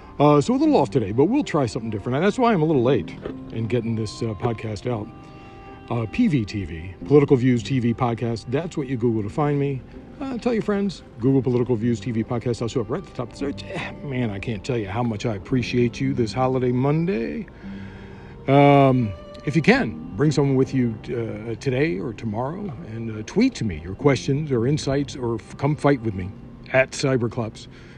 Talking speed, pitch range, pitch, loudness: 210 wpm, 115-140 Hz, 125 Hz, -22 LUFS